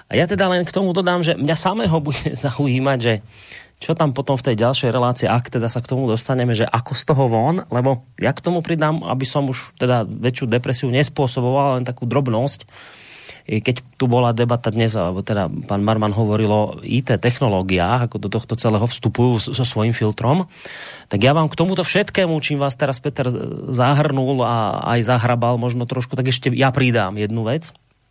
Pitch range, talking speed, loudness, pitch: 115-140 Hz, 190 wpm, -19 LUFS, 125 Hz